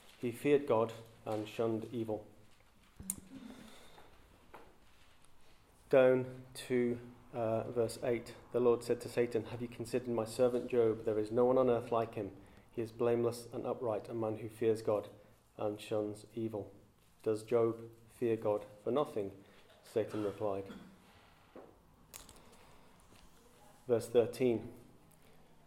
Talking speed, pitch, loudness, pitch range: 125 wpm, 115 Hz, -36 LUFS, 105-120 Hz